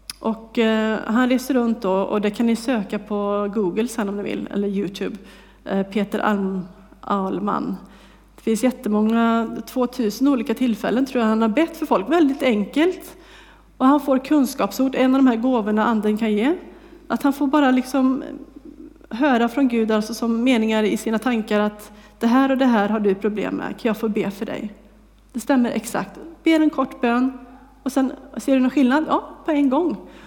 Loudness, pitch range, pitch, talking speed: -21 LUFS, 215-270 Hz, 235 Hz, 185 wpm